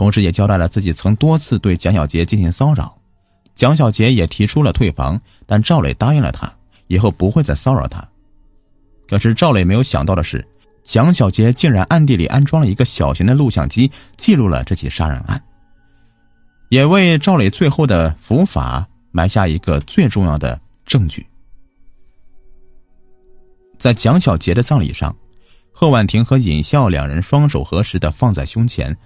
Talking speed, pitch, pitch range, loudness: 255 characters per minute, 105 Hz, 90-130 Hz, -14 LUFS